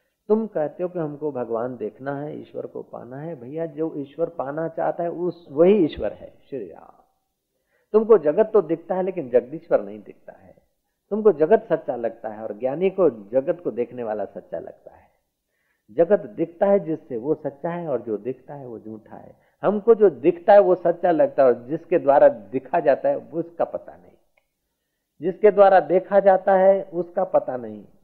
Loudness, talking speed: -21 LUFS, 190 wpm